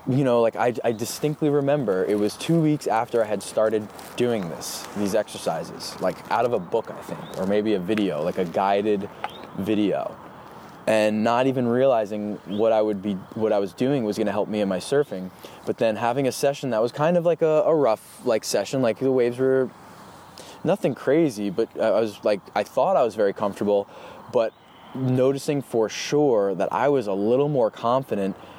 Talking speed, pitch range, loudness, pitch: 200 wpm, 105-135 Hz, -23 LUFS, 110 Hz